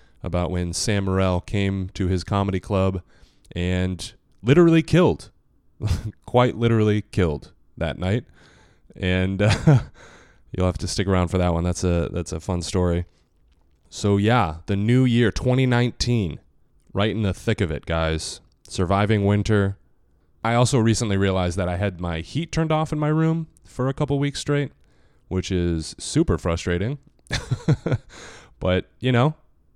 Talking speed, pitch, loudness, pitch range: 150 wpm, 100 Hz, -22 LUFS, 90-120 Hz